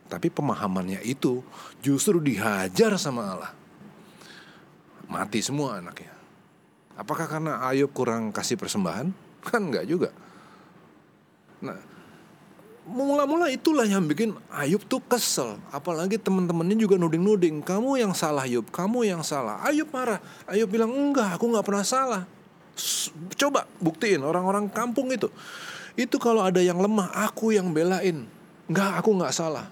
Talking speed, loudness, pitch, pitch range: 130 wpm, -25 LUFS, 190 Hz, 160-225 Hz